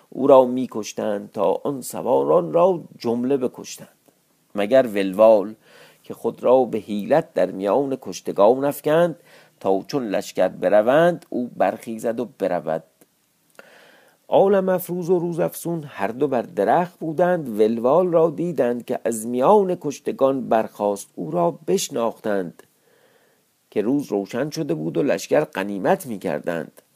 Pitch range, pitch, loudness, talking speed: 110-170 Hz, 135 Hz, -21 LUFS, 130 wpm